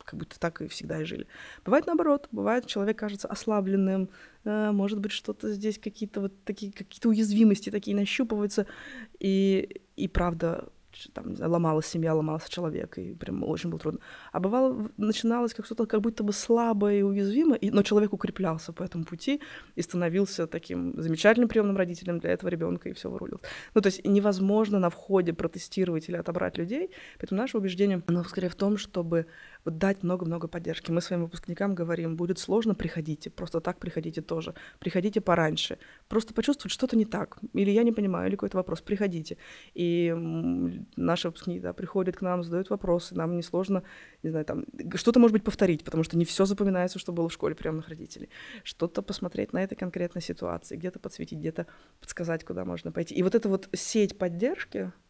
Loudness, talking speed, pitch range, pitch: -29 LUFS, 180 wpm, 170-210 Hz, 190 Hz